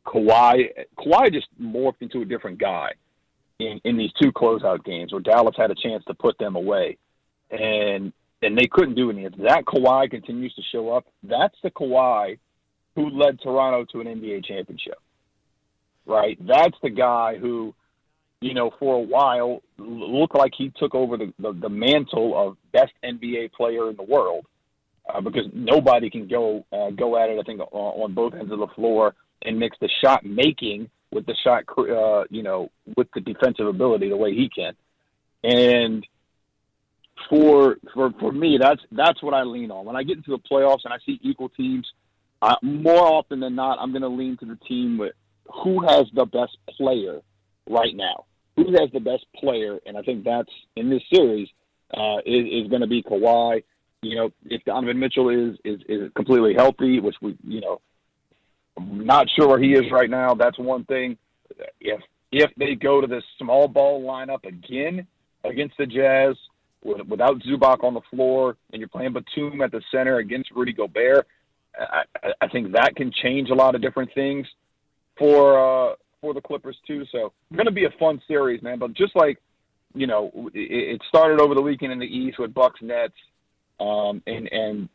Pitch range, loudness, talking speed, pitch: 115-140 Hz, -21 LUFS, 190 wpm, 130 Hz